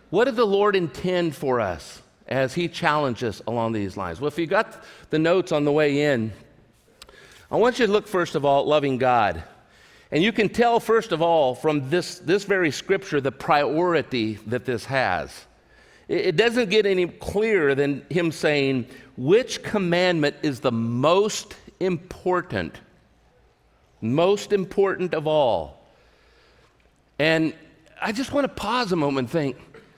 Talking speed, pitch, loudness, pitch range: 160 wpm, 160 Hz, -23 LUFS, 135-195 Hz